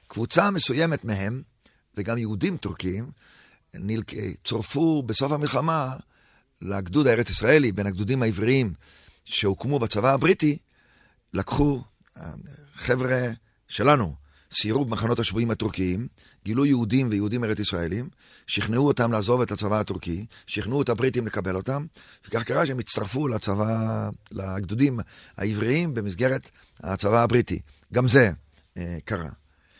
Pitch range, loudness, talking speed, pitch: 100-130 Hz, -24 LUFS, 110 wpm, 115 Hz